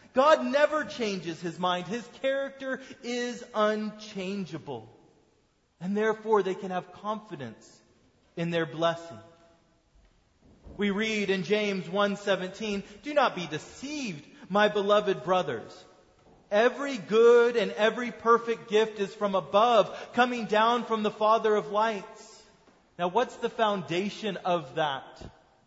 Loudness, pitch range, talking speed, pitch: -28 LUFS, 185-230 Hz, 120 wpm, 210 Hz